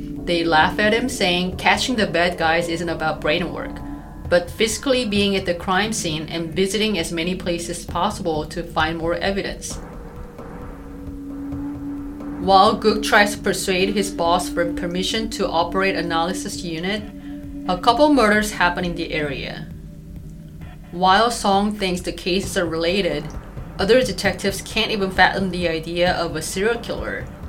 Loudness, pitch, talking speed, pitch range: -20 LUFS, 180 Hz, 150 wpm, 165-200 Hz